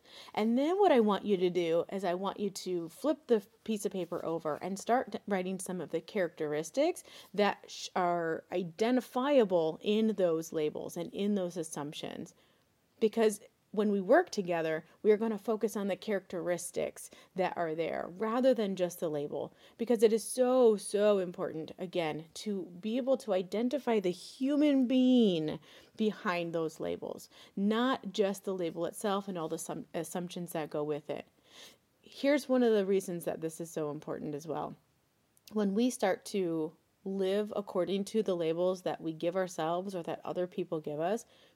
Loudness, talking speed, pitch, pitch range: -33 LUFS, 170 wpm, 190 Hz, 170-220 Hz